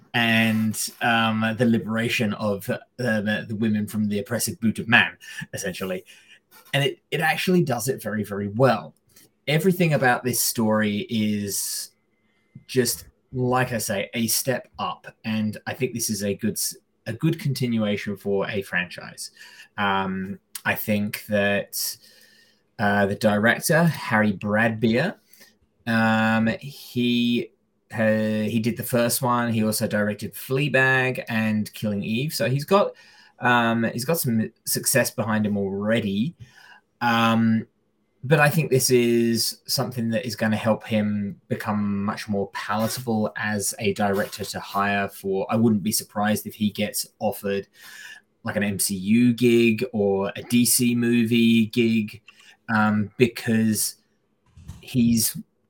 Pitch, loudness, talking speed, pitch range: 110 Hz, -23 LUFS, 140 wpm, 105-120 Hz